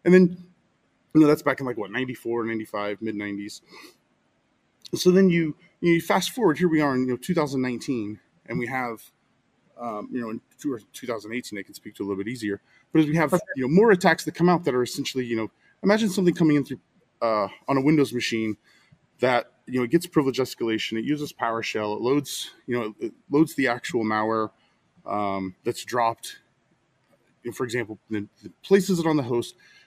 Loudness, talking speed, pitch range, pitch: -24 LUFS, 205 wpm, 110-165 Hz, 130 Hz